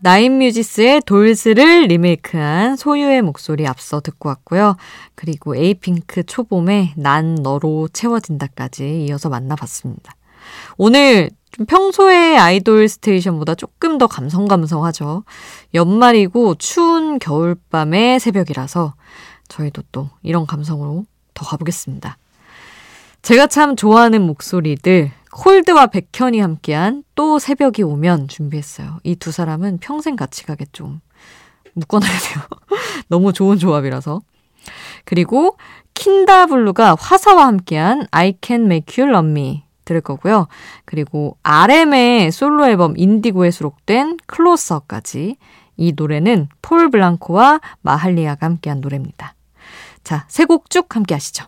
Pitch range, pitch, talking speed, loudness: 155-240 Hz, 185 Hz, 300 characters per minute, -13 LUFS